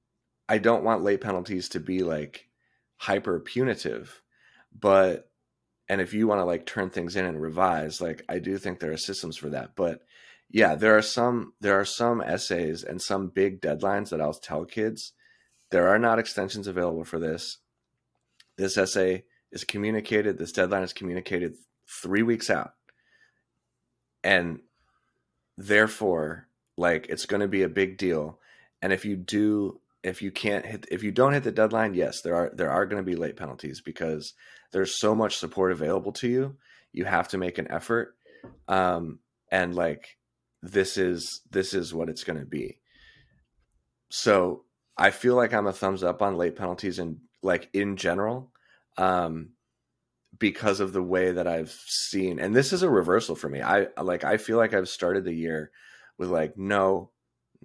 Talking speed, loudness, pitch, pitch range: 175 wpm, -27 LUFS, 95 Hz, 90-110 Hz